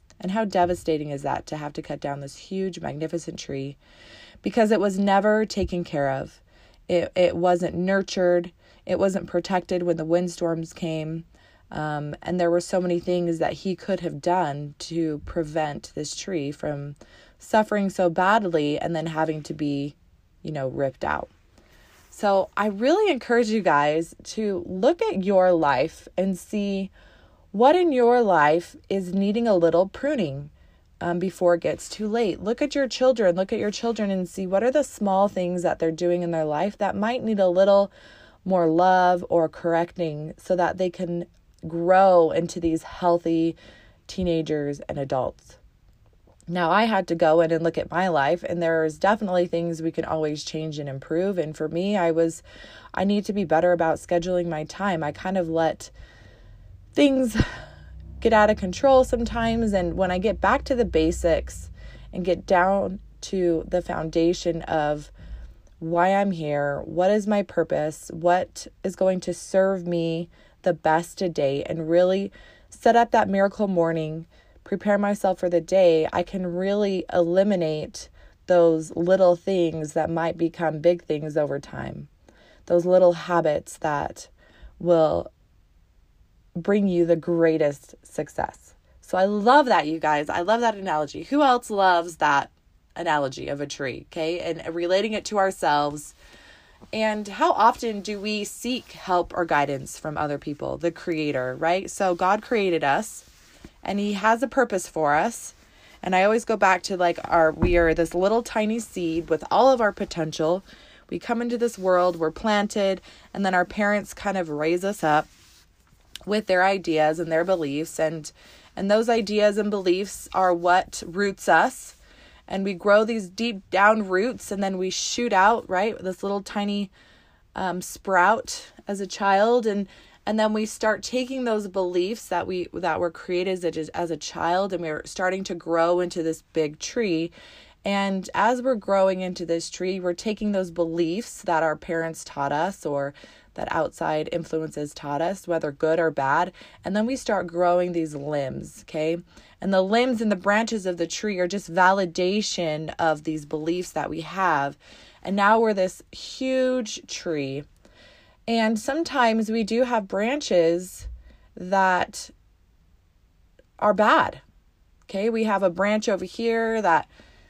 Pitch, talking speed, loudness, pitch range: 180 Hz, 165 wpm, -23 LUFS, 160-200 Hz